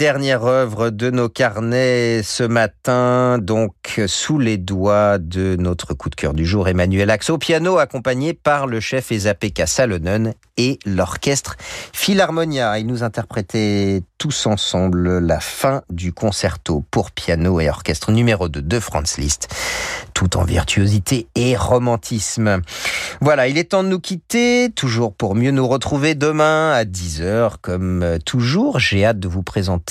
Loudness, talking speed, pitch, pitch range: -18 LUFS, 155 wpm, 110 Hz, 95-130 Hz